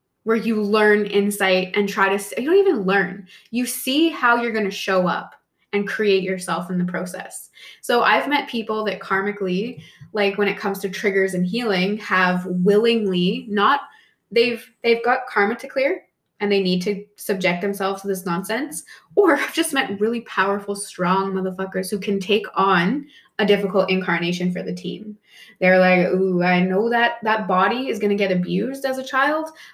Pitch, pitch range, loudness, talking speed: 200 Hz, 190-230 Hz, -20 LUFS, 180 wpm